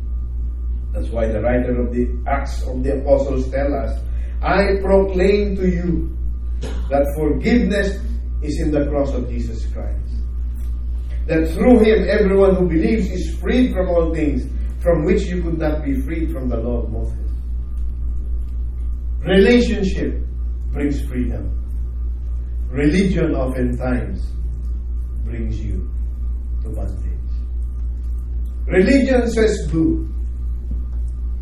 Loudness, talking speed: -20 LUFS, 115 wpm